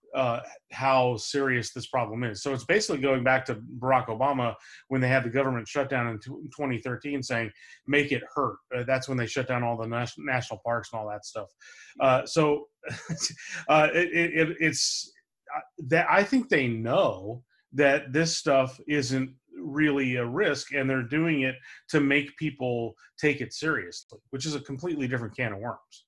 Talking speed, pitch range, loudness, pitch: 180 wpm, 120-145 Hz, -27 LUFS, 130 Hz